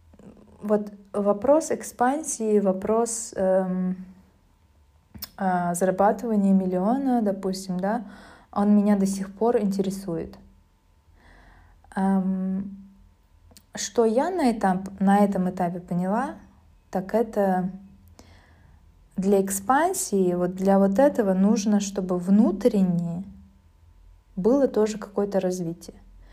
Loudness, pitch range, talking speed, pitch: -24 LUFS, 175-210 Hz, 90 wpm, 195 Hz